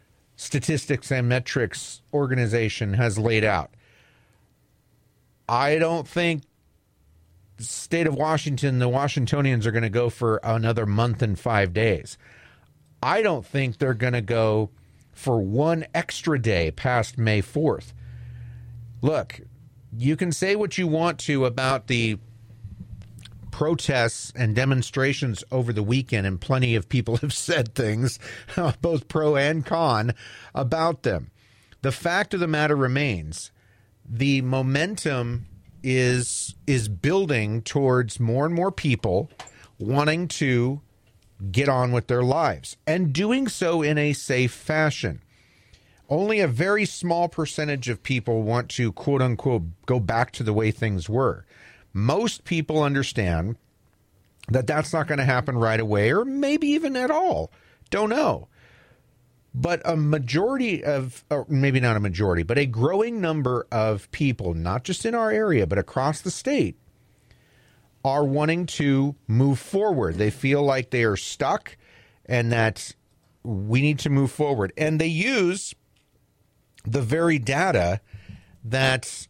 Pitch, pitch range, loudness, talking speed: 130 Hz, 110-150 Hz, -24 LUFS, 140 wpm